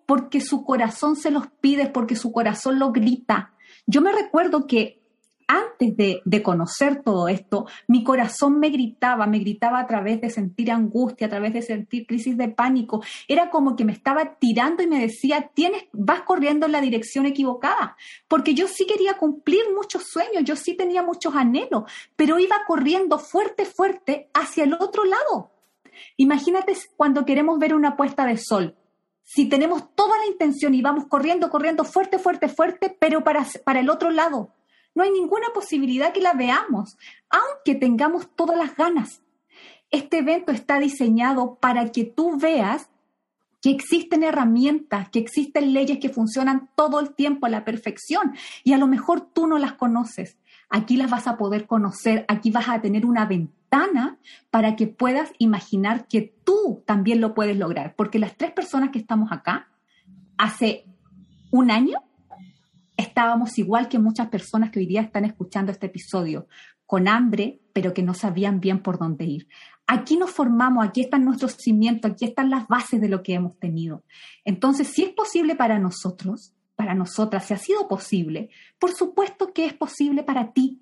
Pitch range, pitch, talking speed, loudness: 220-310 Hz, 255 Hz, 175 wpm, -22 LUFS